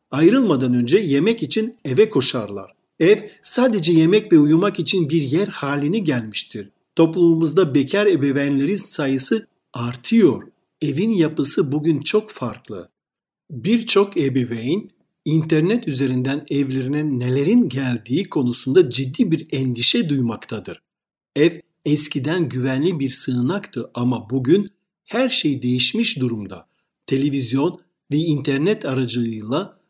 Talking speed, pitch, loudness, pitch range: 105 wpm, 145 Hz, -19 LUFS, 130-180 Hz